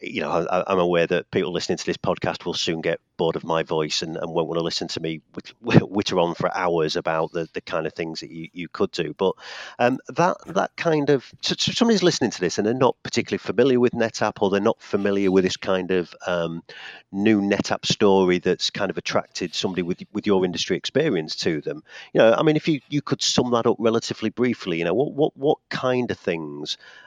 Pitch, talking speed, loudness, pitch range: 100 Hz, 235 wpm, -23 LUFS, 85-125 Hz